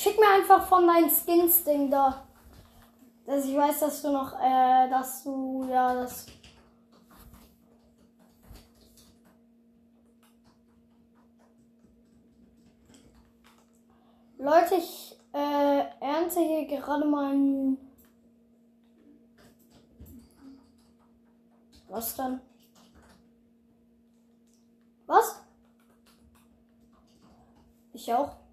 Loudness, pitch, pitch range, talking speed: -25 LUFS, 235 Hz, 230-275 Hz, 65 wpm